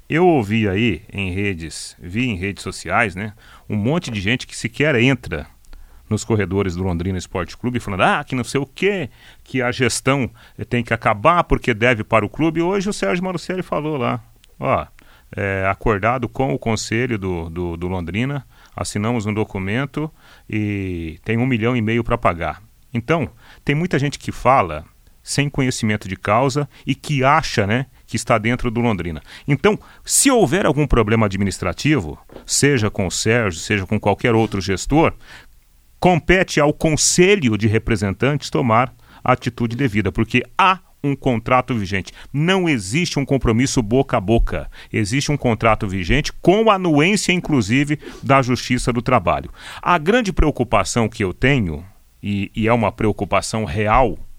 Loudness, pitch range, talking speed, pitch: -19 LUFS, 105-140 Hz, 160 wpm, 120 Hz